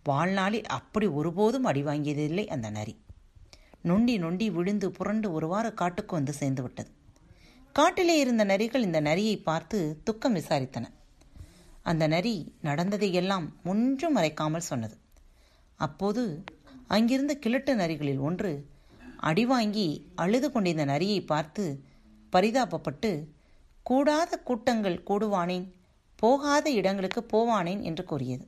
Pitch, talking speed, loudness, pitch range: 185 Hz, 100 wpm, -28 LUFS, 150-220 Hz